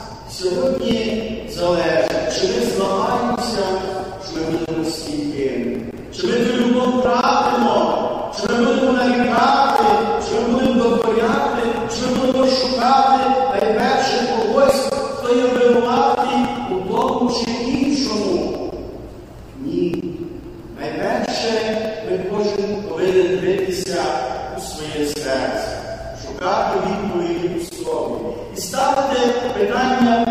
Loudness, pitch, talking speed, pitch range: -18 LUFS, 230 Hz, 105 wpm, 185-255 Hz